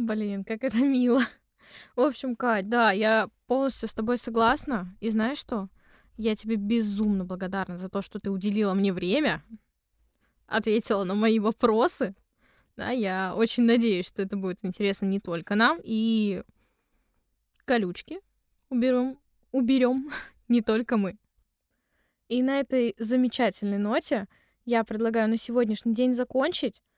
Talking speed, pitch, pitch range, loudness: 135 wpm, 225 Hz, 205-250 Hz, -26 LUFS